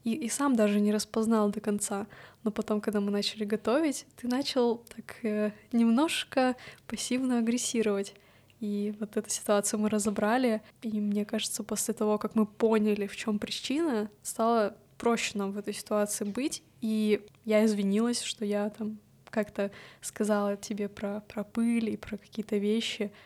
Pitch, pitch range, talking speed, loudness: 215 Hz, 210-230 Hz, 155 wpm, -30 LUFS